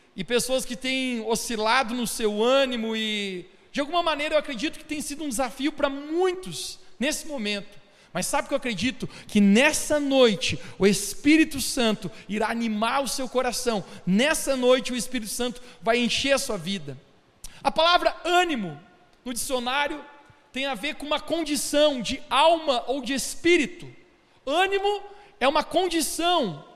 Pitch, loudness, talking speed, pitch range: 260 Hz, -24 LUFS, 155 wpm, 220-295 Hz